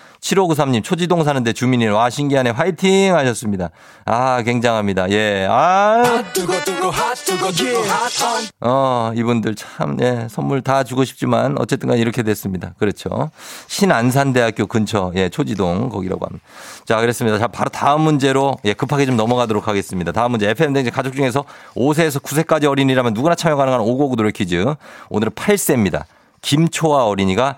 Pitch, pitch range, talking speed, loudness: 130 Hz, 115-150 Hz, 345 characters per minute, -17 LUFS